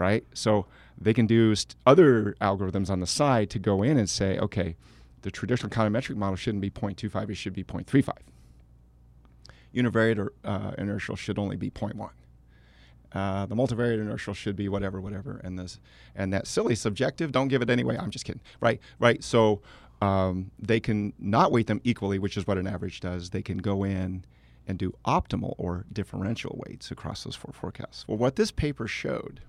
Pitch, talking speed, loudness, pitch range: 100 Hz, 185 wpm, -27 LUFS, 95-115 Hz